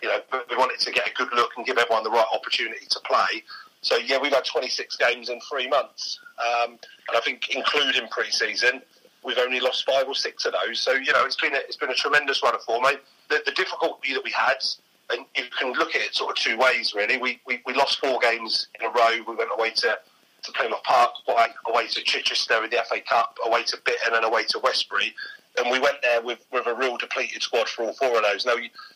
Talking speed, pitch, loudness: 250 wpm, 135 Hz, -23 LUFS